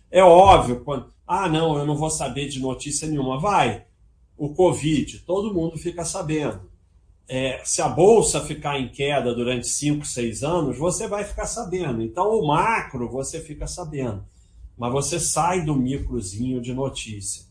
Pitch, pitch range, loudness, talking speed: 145 Hz, 120-165 Hz, -22 LUFS, 160 wpm